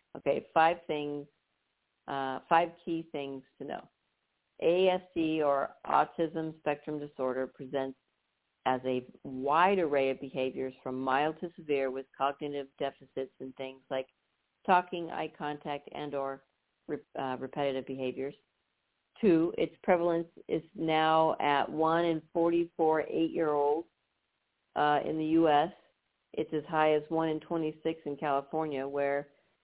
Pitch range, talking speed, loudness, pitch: 135-160 Hz, 130 wpm, -31 LUFS, 150 Hz